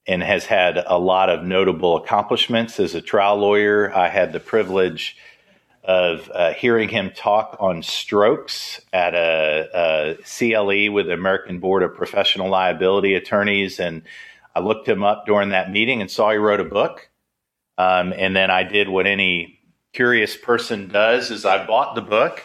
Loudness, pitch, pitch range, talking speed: -19 LUFS, 95 Hz, 90-105 Hz, 170 wpm